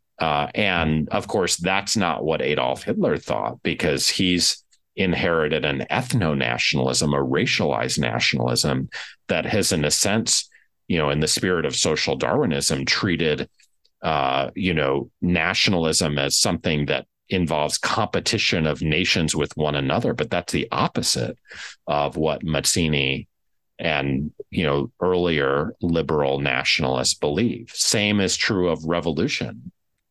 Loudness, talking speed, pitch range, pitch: -21 LUFS, 130 wpm, 70-85 Hz, 75 Hz